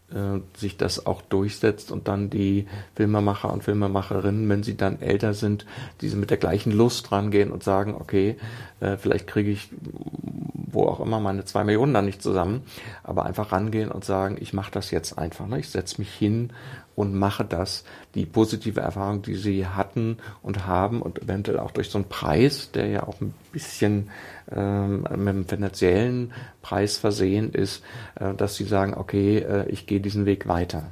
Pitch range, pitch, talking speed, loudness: 95-105 Hz, 100 Hz, 180 wpm, -25 LUFS